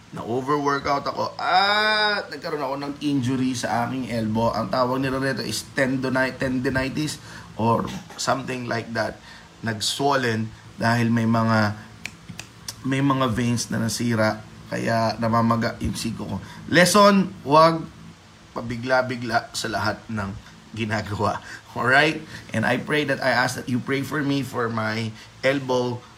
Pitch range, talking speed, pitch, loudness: 115-135 Hz, 135 wpm, 120 Hz, -23 LUFS